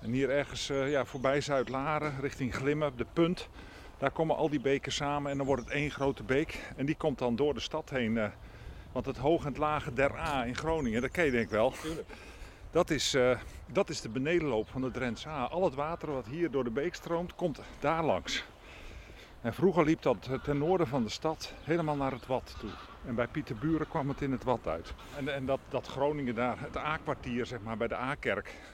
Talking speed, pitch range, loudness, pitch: 230 wpm, 120-150 Hz, -33 LUFS, 135 Hz